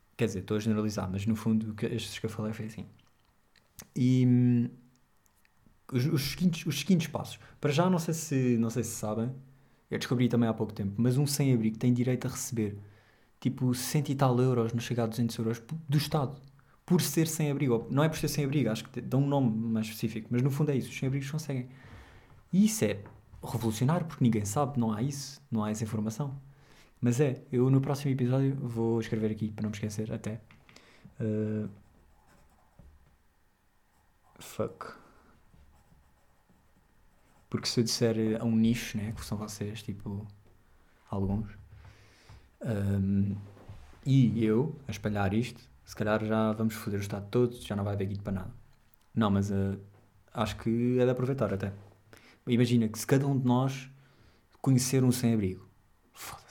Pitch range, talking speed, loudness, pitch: 105-130 Hz, 185 wpm, -30 LUFS, 115 Hz